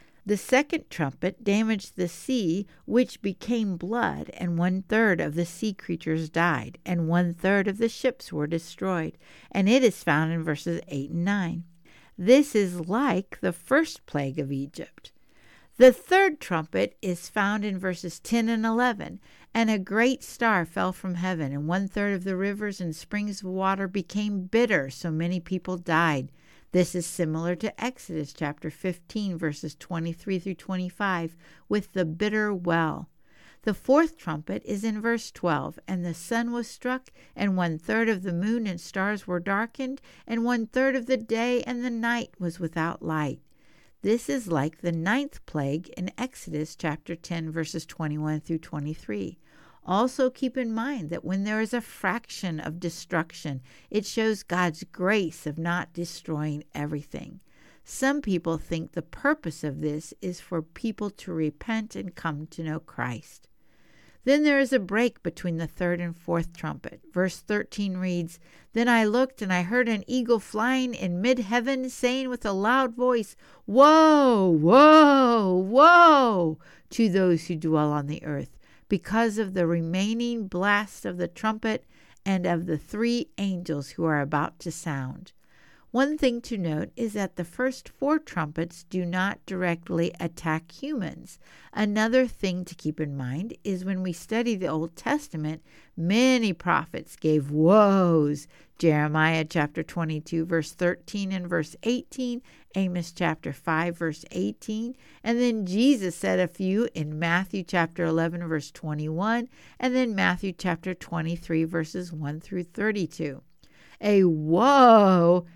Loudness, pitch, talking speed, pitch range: -26 LUFS, 185 Hz, 155 wpm, 165-225 Hz